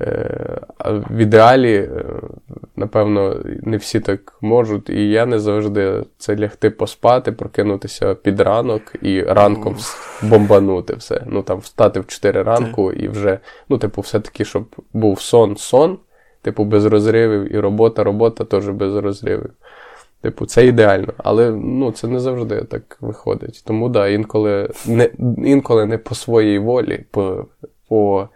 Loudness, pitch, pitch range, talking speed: -16 LUFS, 110 Hz, 105-115 Hz, 140 wpm